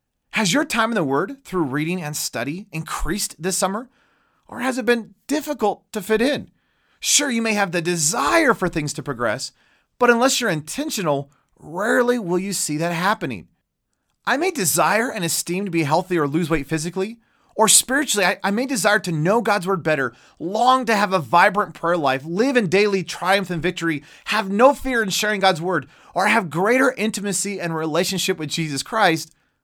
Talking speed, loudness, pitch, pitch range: 190 wpm, -20 LUFS, 195 Hz, 165-230 Hz